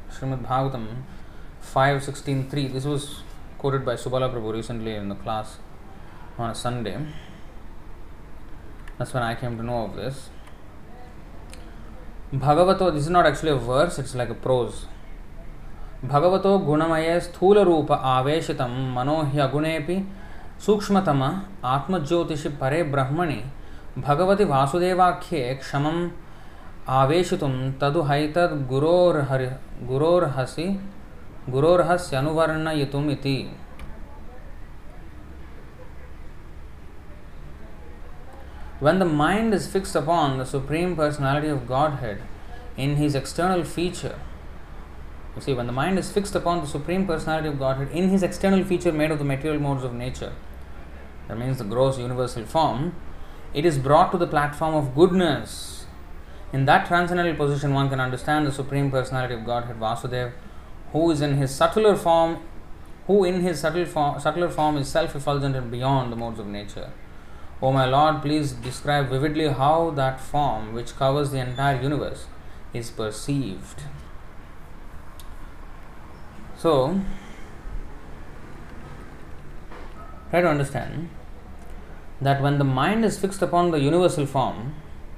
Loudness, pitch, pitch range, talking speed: -23 LUFS, 135 Hz, 95-155 Hz, 95 wpm